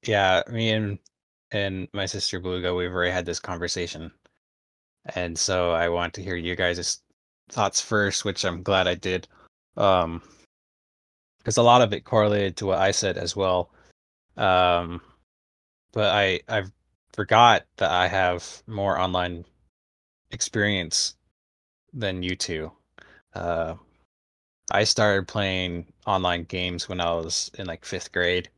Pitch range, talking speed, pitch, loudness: 85-95 Hz, 140 wpm, 90 Hz, -24 LUFS